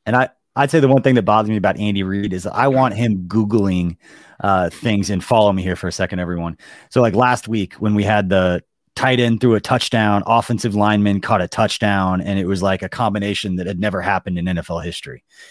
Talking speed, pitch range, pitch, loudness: 230 wpm, 95-115 Hz, 105 Hz, -18 LUFS